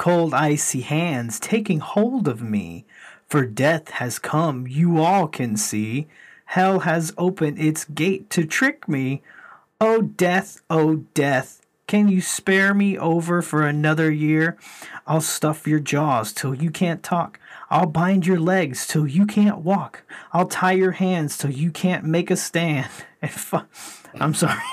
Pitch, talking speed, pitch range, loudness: 165 Hz, 160 wpm, 150-185 Hz, -21 LUFS